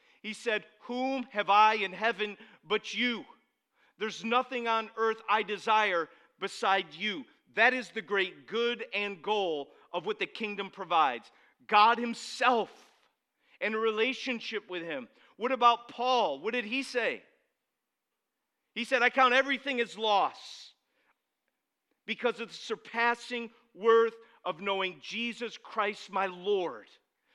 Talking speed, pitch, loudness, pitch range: 135 wpm, 225 Hz, -30 LUFS, 205-245 Hz